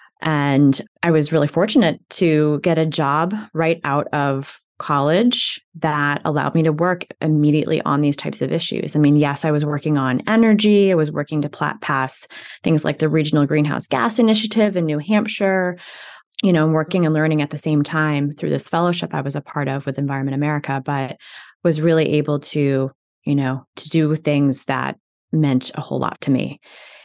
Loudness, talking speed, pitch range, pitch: -19 LUFS, 185 wpm, 145-165 Hz, 155 Hz